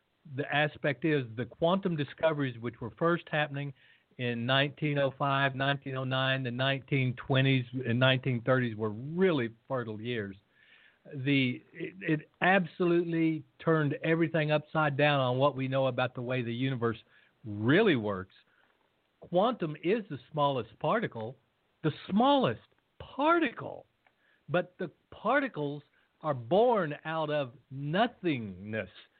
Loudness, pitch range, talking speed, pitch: -30 LUFS, 130-160 Hz, 115 wpm, 140 Hz